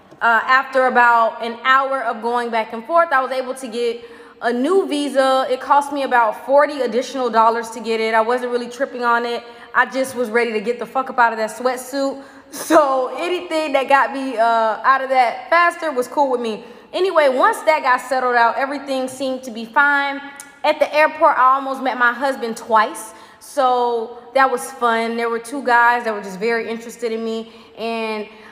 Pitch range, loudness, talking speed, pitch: 230-275 Hz, -18 LUFS, 205 wpm, 250 Hz